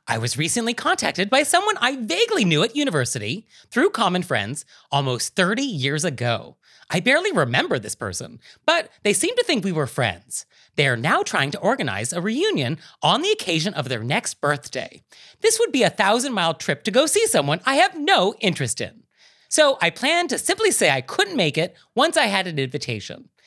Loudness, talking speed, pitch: -21 LUFS, 195 wpm, 195 Hz